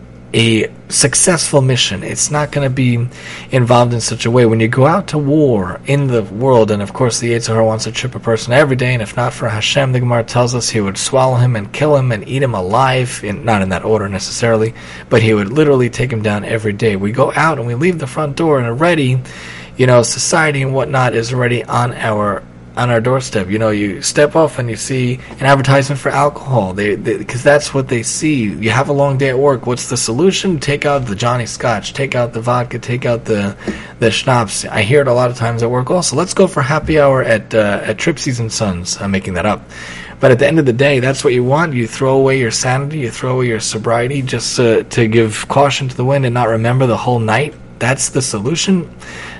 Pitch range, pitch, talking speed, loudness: 110-140 Hz, 125 Hz, 240 wpm, -14 LUFS